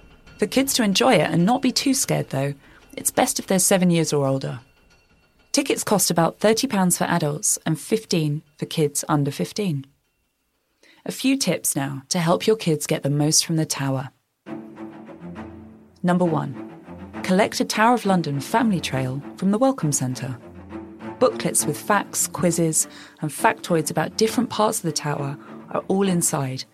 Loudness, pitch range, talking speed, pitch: -21 LUFS, 135-205 Hz, 165 wpm, 160 Hz